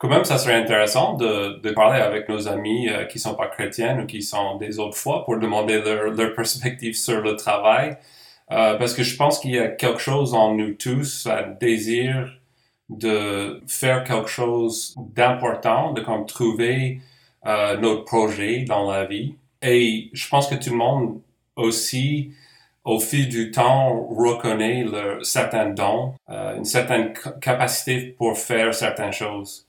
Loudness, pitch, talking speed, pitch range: -21 LUFS, 115 Hz, 170 wpm, 110-130 Hz